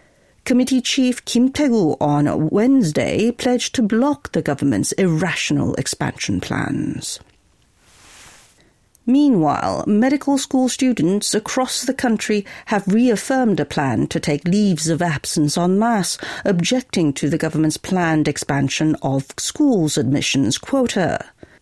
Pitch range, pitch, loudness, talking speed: 155-250 Hz, 205 Hz, -18 LUFS, 115 wpm